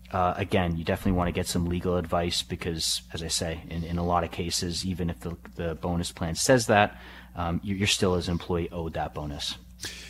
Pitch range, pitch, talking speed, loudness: 85-90 Hz, 85 Hz, 220 wpm, -28 LUFS